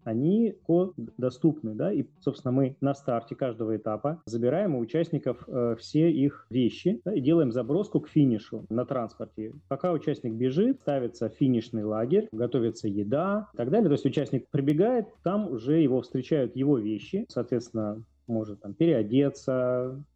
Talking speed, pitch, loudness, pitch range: 150 wpm, 135 Hz, -28 LUFS, 115-155 Hz